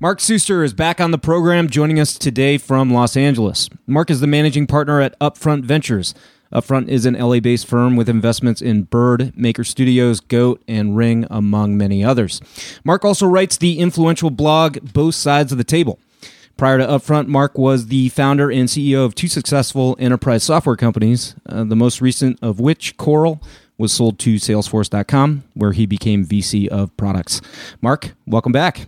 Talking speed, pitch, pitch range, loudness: 175 wpm, 130 Hz, 115-150 Hz, -16 LUFS